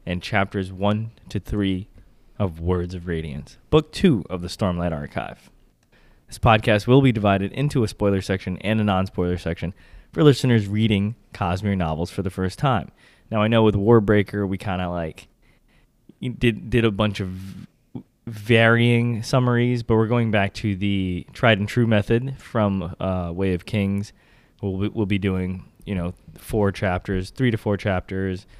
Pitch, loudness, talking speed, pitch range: 100 Hz, -22 LUFS, 170 wpm, 95-110 Hz